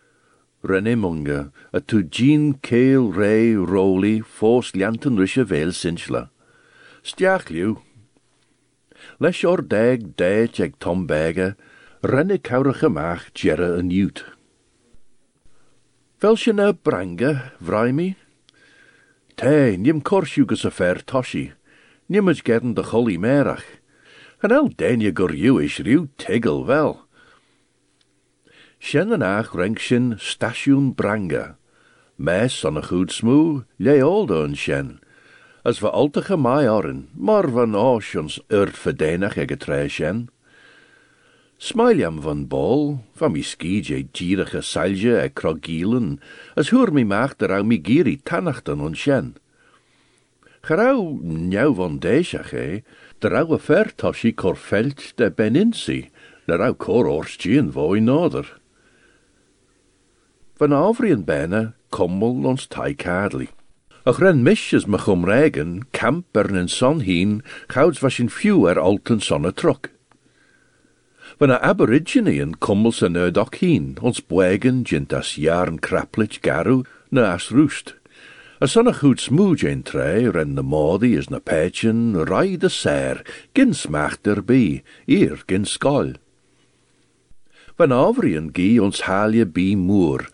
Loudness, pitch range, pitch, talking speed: -19 LUFS, 95-150 Hz, 115 Hz, 120 wpm